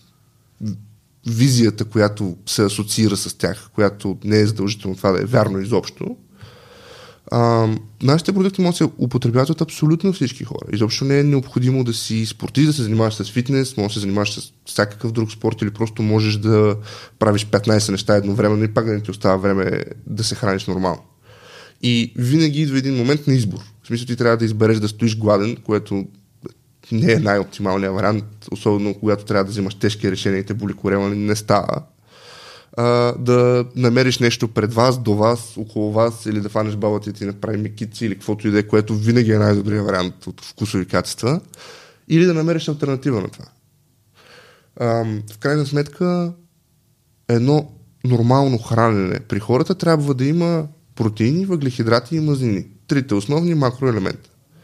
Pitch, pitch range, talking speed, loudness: 115 Hz, 105-130 Hz, 170 wpm, -19 LUFS